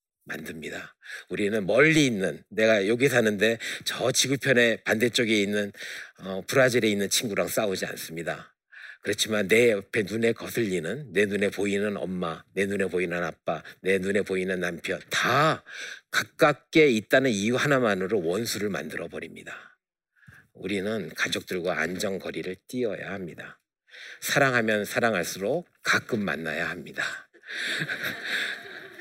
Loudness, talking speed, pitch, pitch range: -26 LUFS, 295 characters per minute, 105 Hz, 95-120 Hz